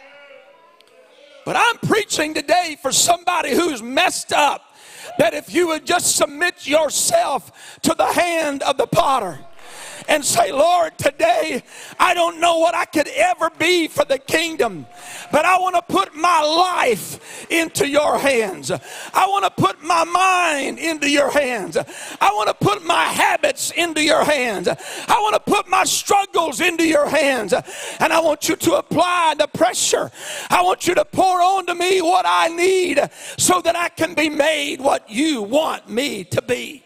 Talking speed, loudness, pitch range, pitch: 170 wpm, -18 LUFS, 300-360 Hz, 330 Hz